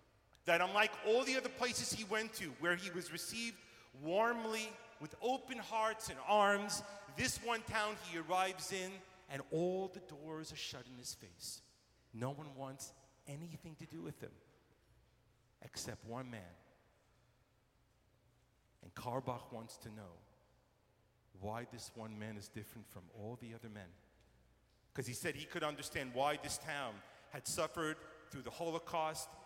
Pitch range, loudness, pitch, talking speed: 120-185 Hz, -41 LUFS, 145 Hz, 155 wpm